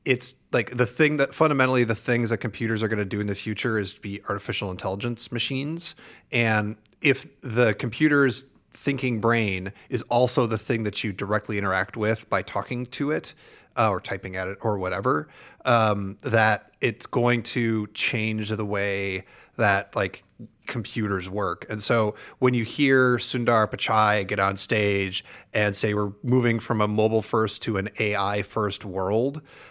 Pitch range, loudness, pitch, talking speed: 105-125 Hz, -25 LUFS, 110 Hz, 170 wpm